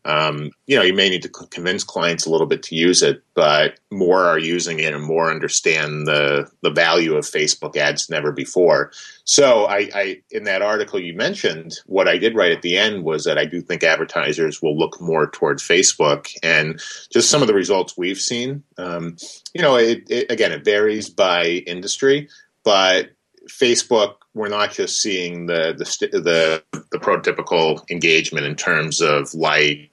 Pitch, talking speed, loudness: 115 Hz, 180 wpm, -18 LUFS